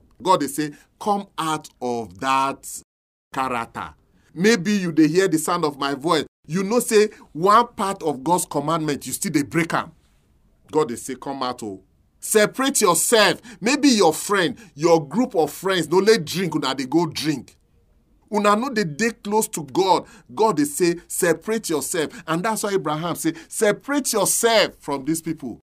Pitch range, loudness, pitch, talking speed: 140-210 Hz, -21 LUFS, 170 Hz, 175 wpm